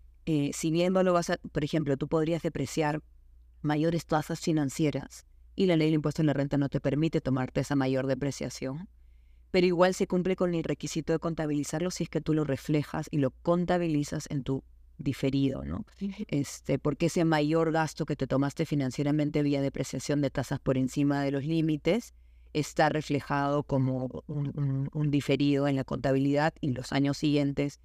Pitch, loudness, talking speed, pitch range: 145 Hz, -29 LUFS, 180 wpm, 135-160 Hz